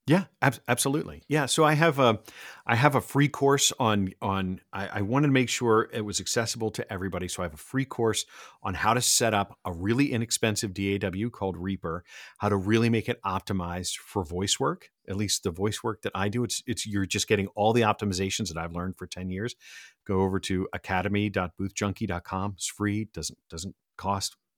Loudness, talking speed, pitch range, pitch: -27 LUFS, 205 wpm, 95-120 Hz, 105 Hz